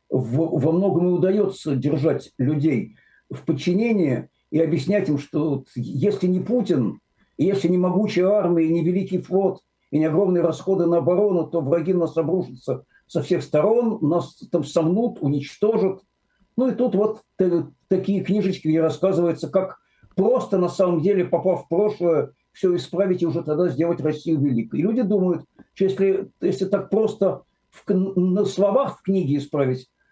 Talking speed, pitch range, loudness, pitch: 155 wpm, 160-195 Hz, -22 LUFS, 180 Hz